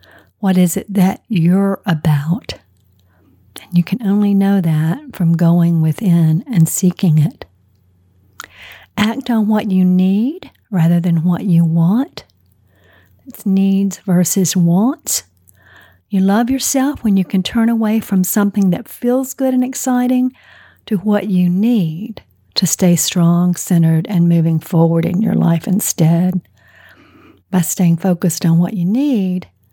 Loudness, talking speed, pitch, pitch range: -15 LUFS, 140 wpm, 185 Hz, 165-205 Hz